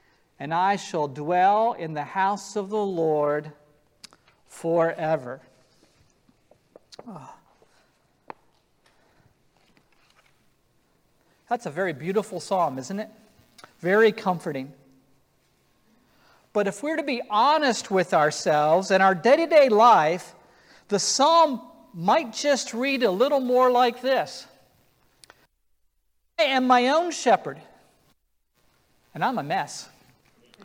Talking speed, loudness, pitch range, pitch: 100 wpm, -23 LUFS, 150-250 Hz, 195 Hz